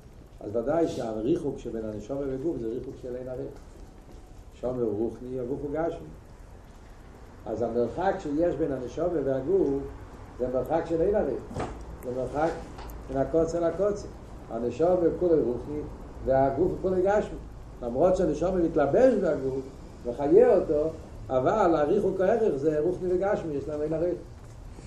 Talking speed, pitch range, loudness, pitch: 135 wpm, 120-165 Hz, -27 LUFS, 140 Hz